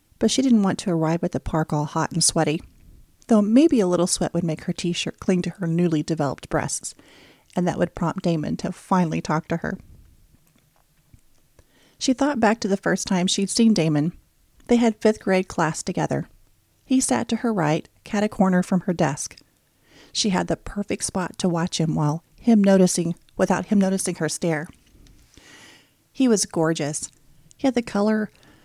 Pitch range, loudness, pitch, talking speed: 160-210 Hz, -22 LUFS, 180 Hz, 185 wpm